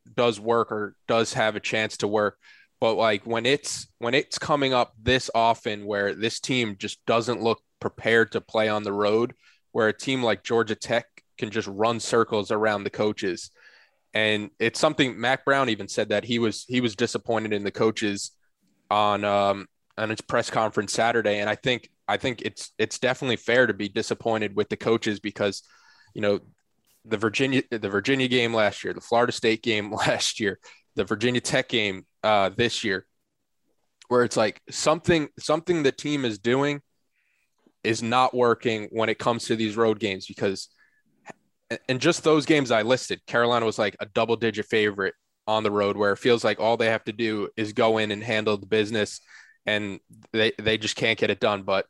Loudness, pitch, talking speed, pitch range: -25 LUFS, 110 Hz, 190 wpm, 105-120 Hz